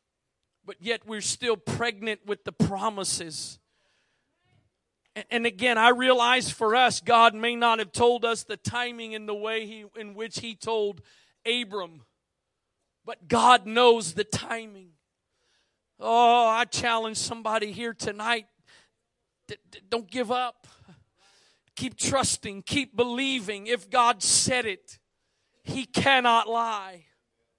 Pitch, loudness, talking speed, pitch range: 225 Hz, -25 LUFS, 125 wpm, 210-240 Hz